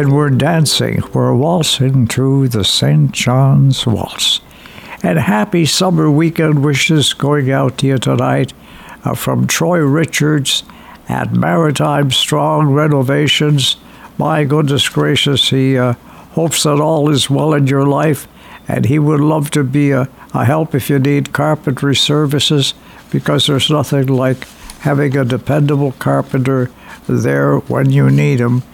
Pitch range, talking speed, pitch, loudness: 130-150 Hz, 140 wpm, 140 Hz, -13 LUFS